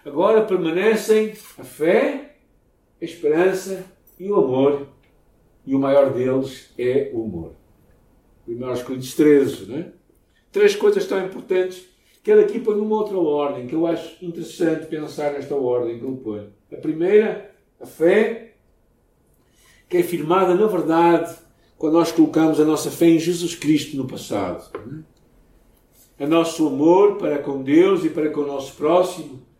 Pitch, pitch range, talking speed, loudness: 165 Hz, 140-205 Hz, 150 wpm, -20 LUFS